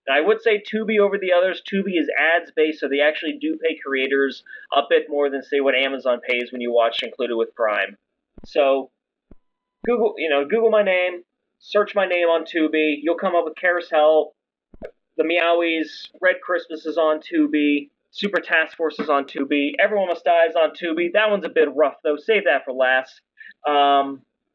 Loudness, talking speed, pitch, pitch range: -20 LUFS, 190 wpm, 160 Hz, 145-180 Hz